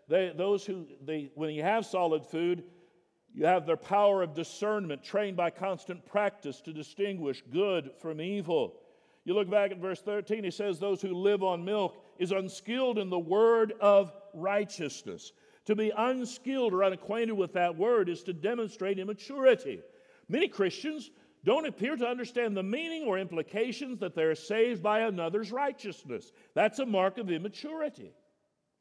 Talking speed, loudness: 160 wpm, -31 LUFS